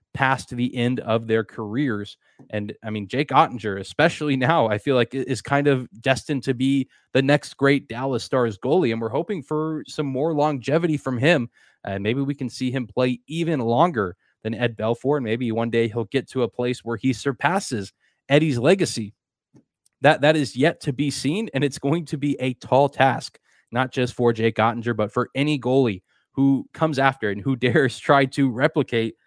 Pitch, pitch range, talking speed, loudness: 130 Hz, 115-145 Hz, 200 wpm, -22 LUFS